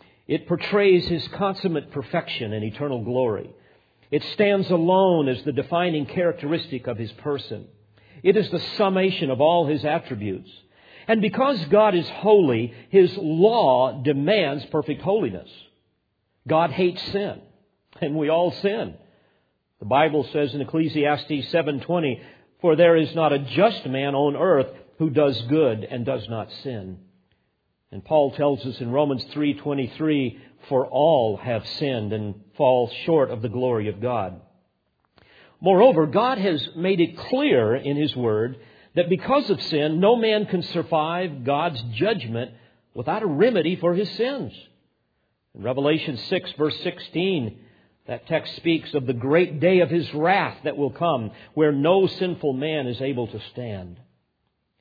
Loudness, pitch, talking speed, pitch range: -22 LUFS, 150 Hz, 150 wpm, 125-175 Hz